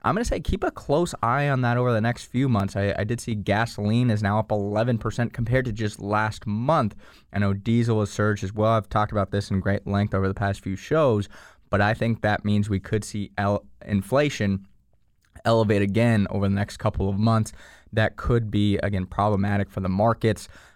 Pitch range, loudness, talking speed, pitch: 100-115 Hz, -24 LUFS, 210 wpm, 105 Hz